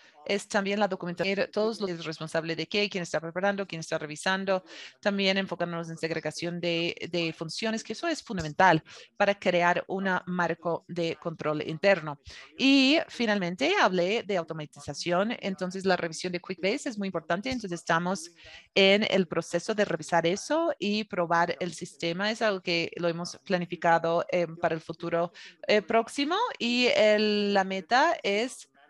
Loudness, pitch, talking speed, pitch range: -28 LUFS, 180 Hz, 155 wpm, 170-205 Hz